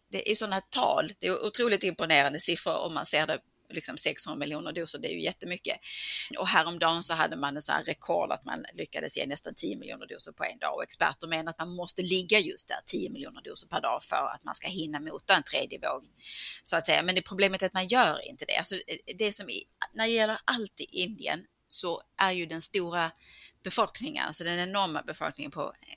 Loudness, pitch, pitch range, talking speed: -29 LUFS, 180 Hz, 165-200 Hz, 225 wpm